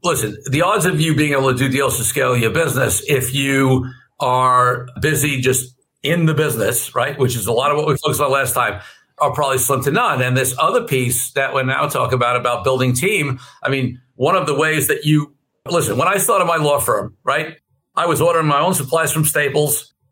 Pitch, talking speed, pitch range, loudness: 135 Hz, 225 wpm, 130-150 Hz, -17 LUFS